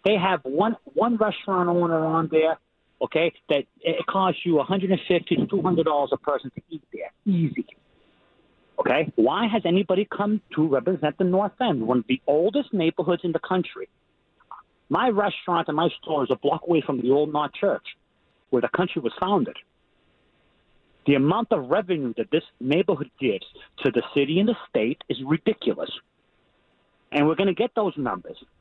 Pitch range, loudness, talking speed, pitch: 155-200 Hz, -24 LUFS, 170 wpm, 175 Hz